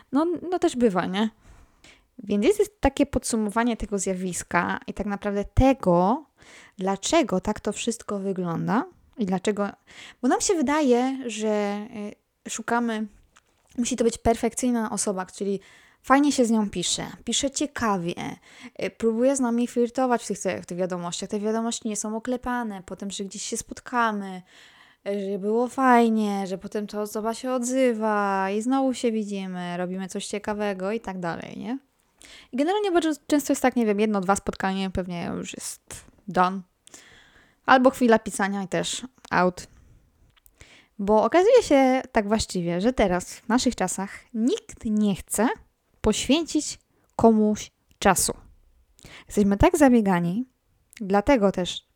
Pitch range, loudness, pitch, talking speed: 200-250 Hz, -24 LUFS, 220 Hz, 140 wpm